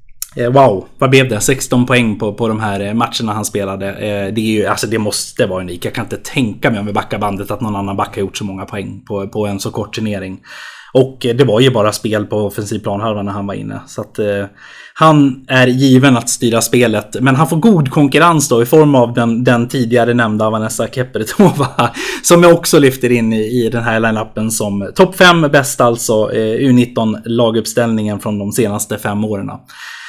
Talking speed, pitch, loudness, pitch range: 210 wpm, 115 Hz, -13 LUFS, 105-130 Hz